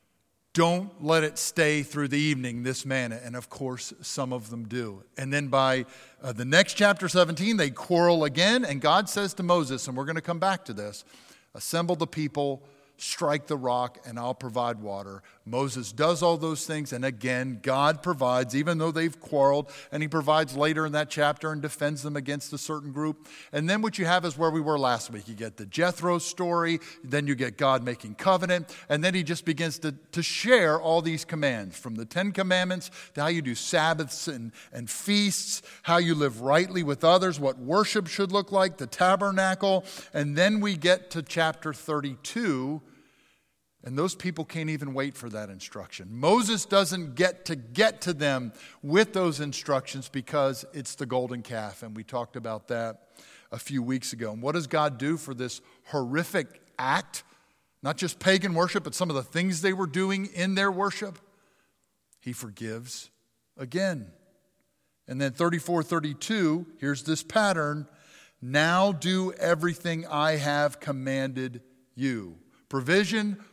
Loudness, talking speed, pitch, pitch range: -27 LUFS, 175 wpm, 150 Hz, 130-175 Hz